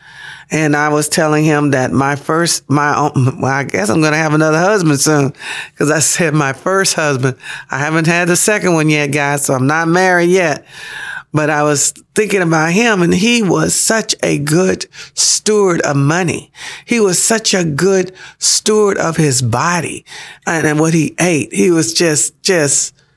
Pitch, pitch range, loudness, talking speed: 160 Hz, 145-180 Hz, -13 LUFS, 180 wpm